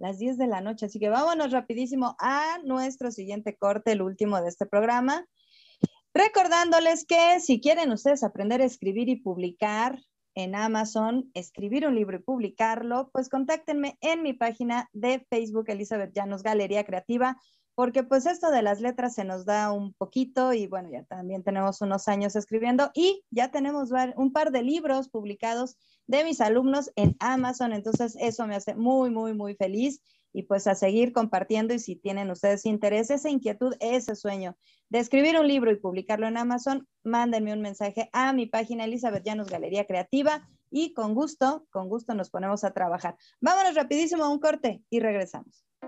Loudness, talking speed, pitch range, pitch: -27 LUFS, 175 wpm, 205-265 Hz, 235 Hz